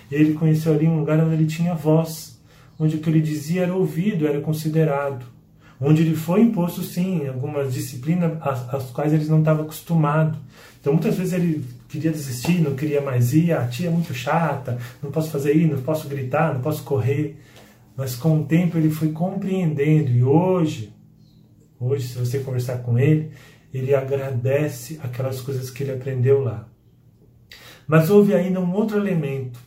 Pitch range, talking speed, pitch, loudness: 135-160 Hz, 175 wpm, 150 Hz, -21 LUFS